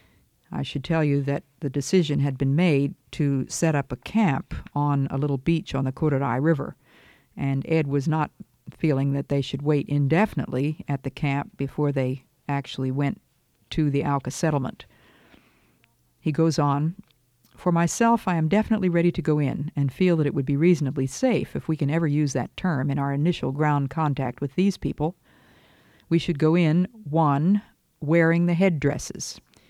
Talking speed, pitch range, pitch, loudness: 175 wpm, 140-165 Hz, 145 Hz, -24 LUFS